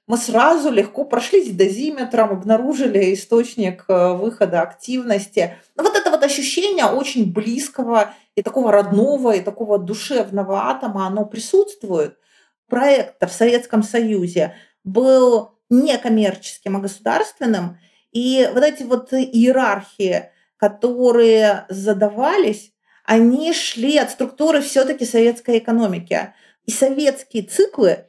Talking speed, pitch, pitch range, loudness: 110 wpm, 230 Hz, 205-260 Hz, -17 LUFS